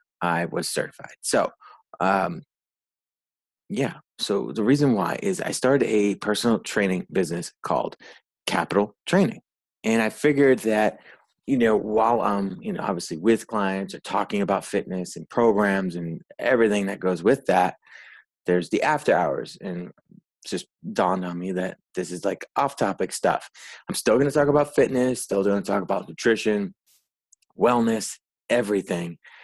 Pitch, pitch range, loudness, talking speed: 105 Hz, 95-115 Hz, -24 LUFS, 155 wpm